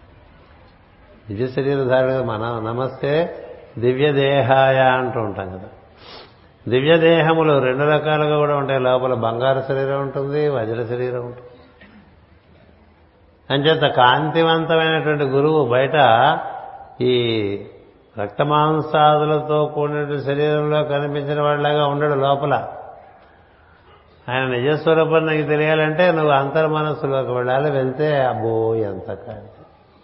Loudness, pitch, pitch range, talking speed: -18 LUFS, 135 Hz, 120-150 Hz, 90 wpm